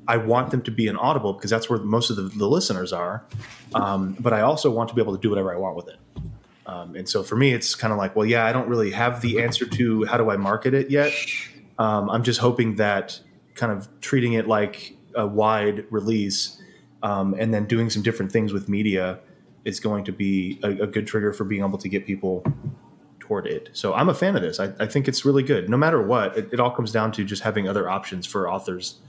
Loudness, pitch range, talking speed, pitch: -23 LUFS, 100-120 Hz, 250 wpm, 110 Hz